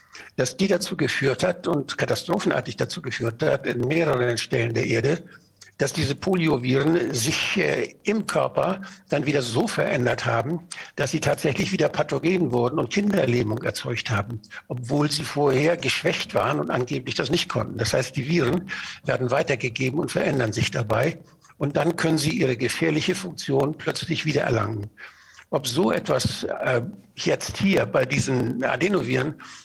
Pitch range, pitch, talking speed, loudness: 125-170 Hz, 145 Hz, 155 wpm, -24 LUFS